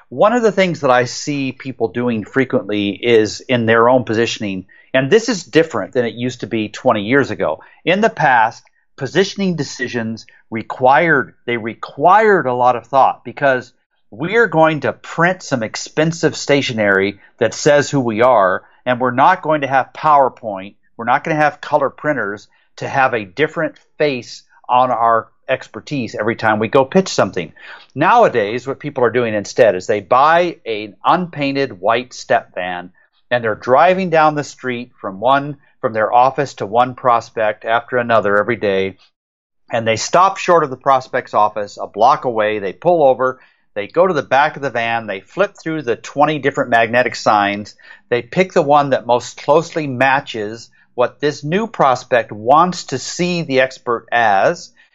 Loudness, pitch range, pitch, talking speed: -16 LUFS, 115-150 Hz, 130 Hz, 175 wpm